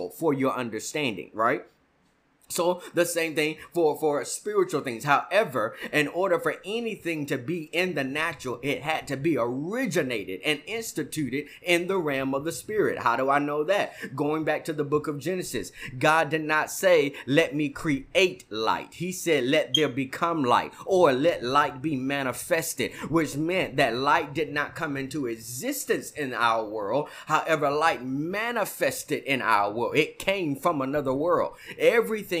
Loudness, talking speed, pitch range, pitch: -26 LUFS, 165 wpm, 140-170 Hz, 155 Hz